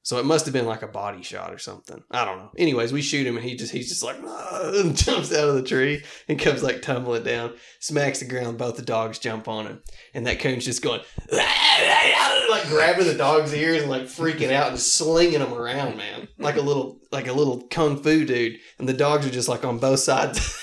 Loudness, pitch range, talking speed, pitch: -22 LUFS, 120-155 Hz, 235 wpm, 135 Hz